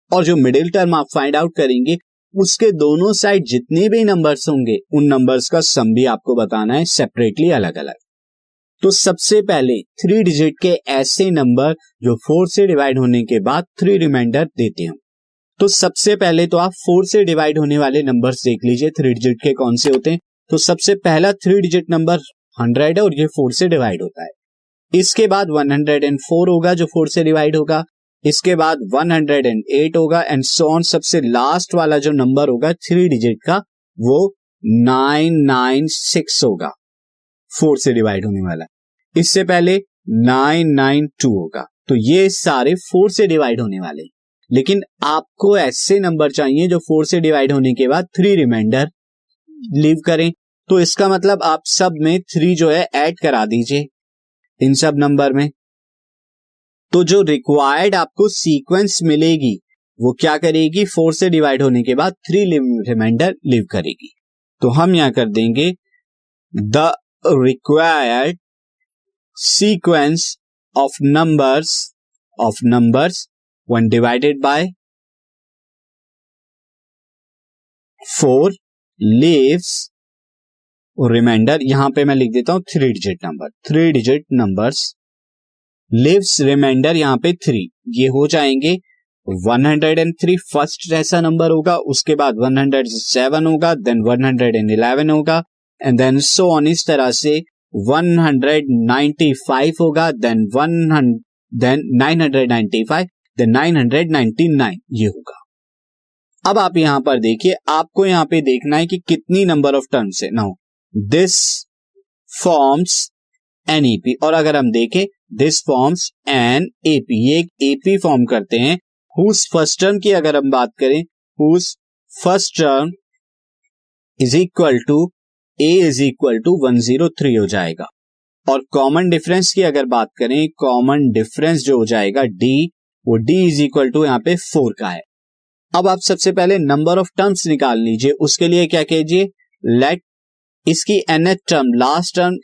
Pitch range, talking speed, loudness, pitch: 130-175 Hz, 145 wpm, -14 LUFS, 155 Hz